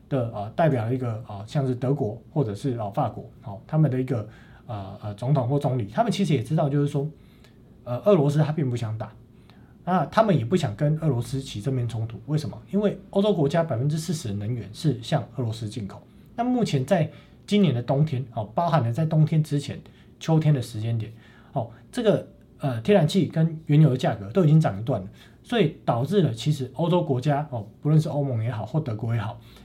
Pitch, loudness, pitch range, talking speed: 140 Hz, -25 LUFS, 115-155 Hz, 330 characters per minute